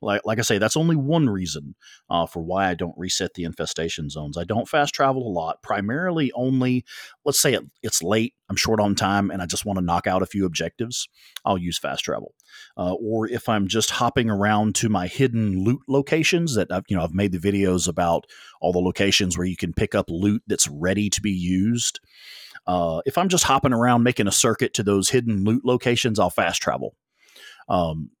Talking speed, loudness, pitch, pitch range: 215 wpm, -22 LUFS, 105 Hz, 90-120 Hz